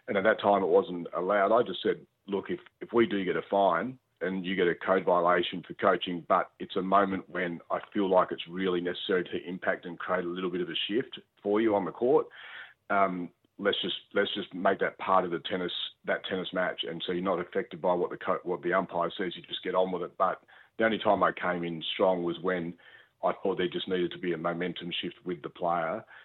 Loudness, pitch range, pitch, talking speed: -30 LUFS, 85-95 Hz, 90 Hz, 245 wpm